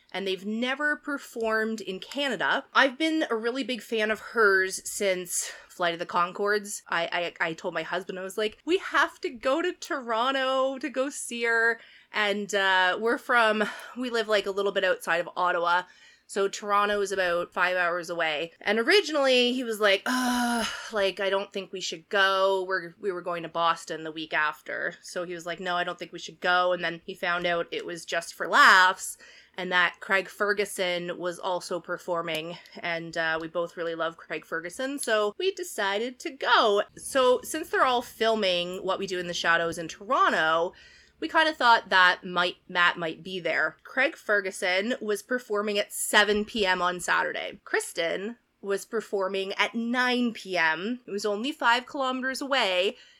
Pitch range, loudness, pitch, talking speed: 175-235 Hz, -26 LUFS, 195 Hz, 185 wpm